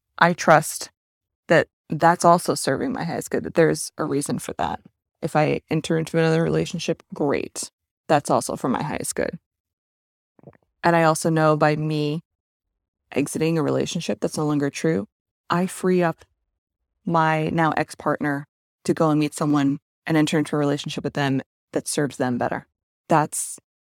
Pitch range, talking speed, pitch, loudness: 140-165 Hz, 165 wpm, 155 Hz, -22 LUFS